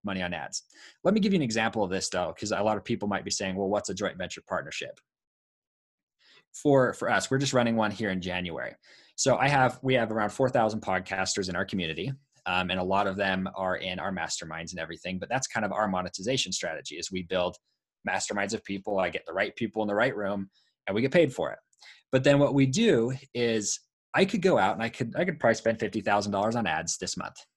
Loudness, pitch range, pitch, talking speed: -28 LUFS, 95-130 Hz, 105 Hz, 245 wpm